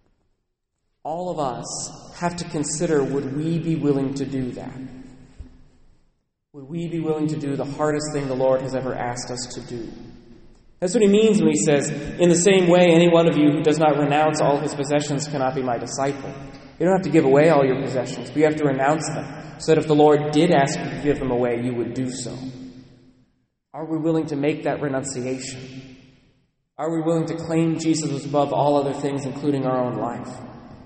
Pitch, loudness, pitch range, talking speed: 145 Hz, -21 LUFS, 130-155 Hz, 210 wpm